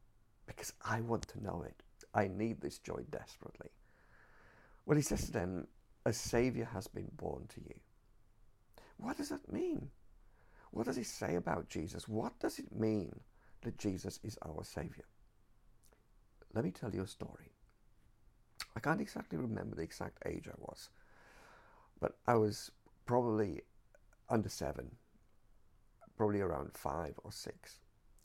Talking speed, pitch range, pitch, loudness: 145 wpm, 100-115 Hz, 110 Hz, -40 LUFS